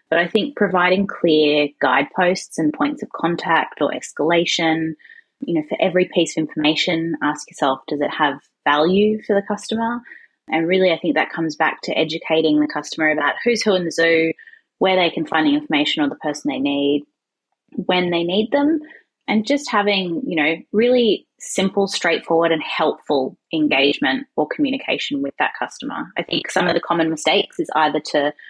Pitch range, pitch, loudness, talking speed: 160-225 Hz, 175 Hz, -19 LUFS, 180 wpm